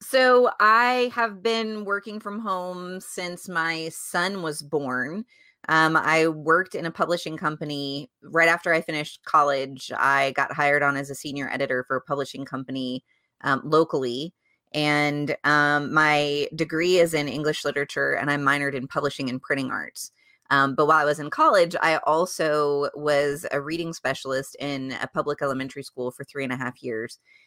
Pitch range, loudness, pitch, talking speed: 140-170 Hz, -24 LUFS, 150 Hz, 170 wpm